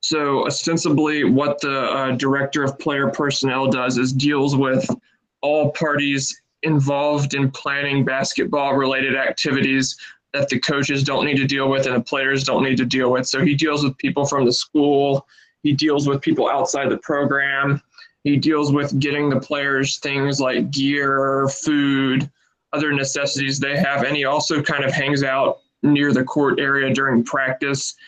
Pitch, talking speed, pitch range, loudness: 140 Hz, 170 wpm, 135-145 Hz, -19 LUFS